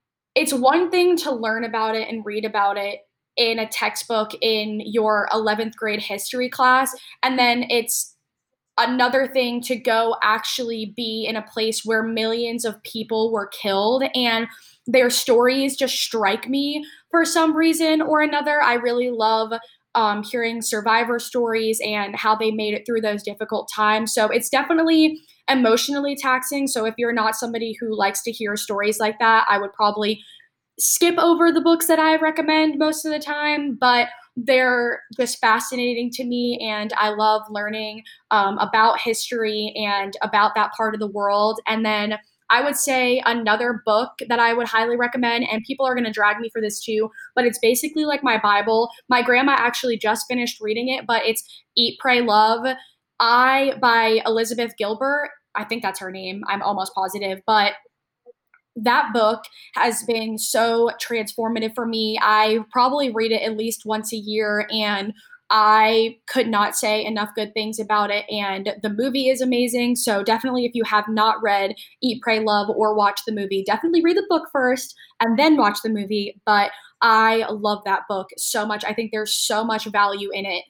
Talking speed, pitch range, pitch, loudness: 180 wpm, 215-250 Hz, 225 Hz, -20 LUFS